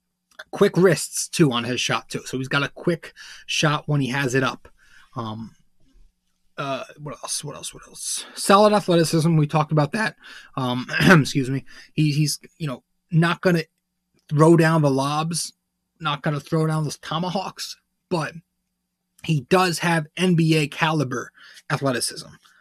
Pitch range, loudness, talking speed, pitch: 140-180 Hz, -21 LUFS, 155 wpm, 160 Hz